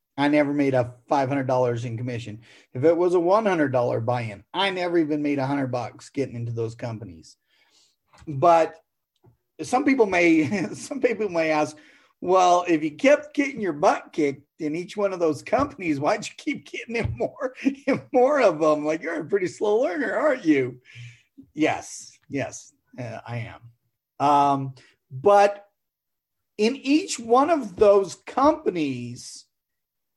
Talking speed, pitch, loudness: 150 wpm, 160 Hz, -23 LUFS